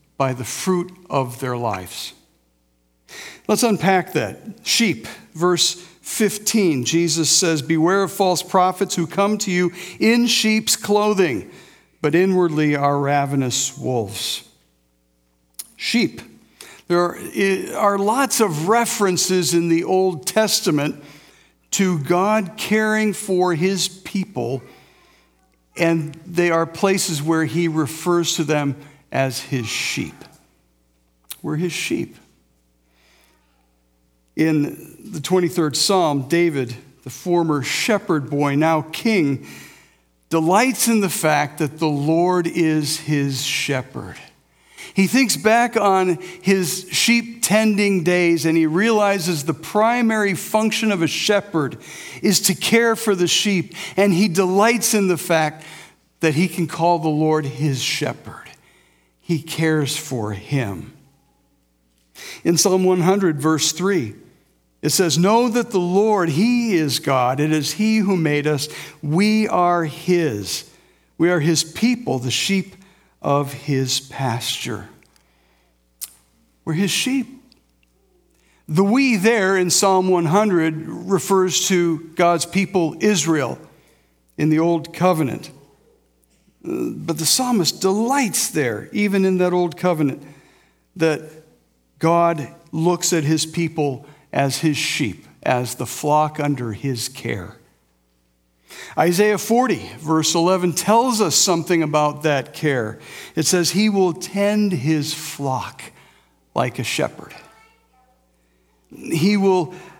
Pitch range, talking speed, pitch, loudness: 140-190 Hz, 120 wpm, 165 Hz, -19 LUFS